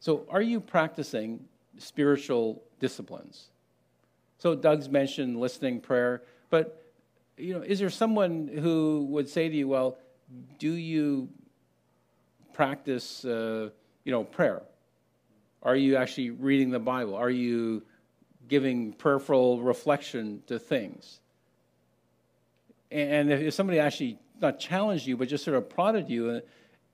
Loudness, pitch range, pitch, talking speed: -28 LUFS, 125-155 Hz, 135 Hz, 125 wpm